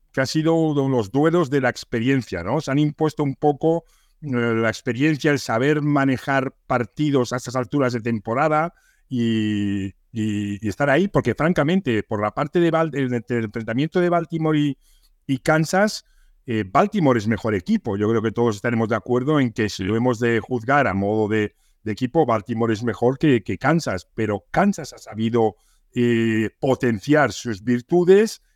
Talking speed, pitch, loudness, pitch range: 180 wpm, 125 Hz, -21 LUFS, 115-150 Hz